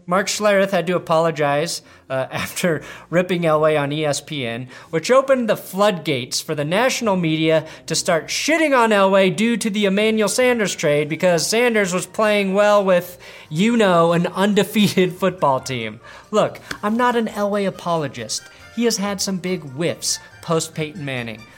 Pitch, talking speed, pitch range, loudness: 180 Hz, 160 wpm, 155-205 Hz, -19 LUFS